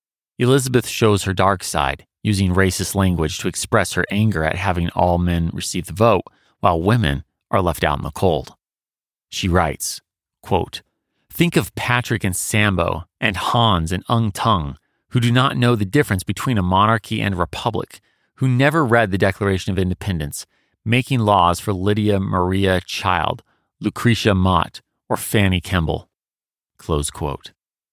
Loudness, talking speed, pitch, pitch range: -19 LUFS, 150 wpm, 100 Hz, 90-115 Hz